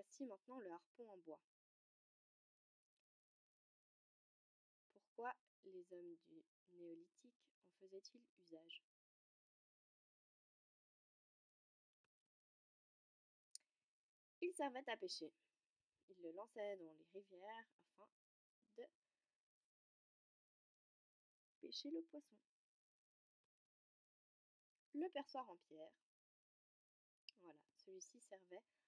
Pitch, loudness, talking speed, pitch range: 215 Hz, -55 LUFS, 75 wpm, 180-290 Hz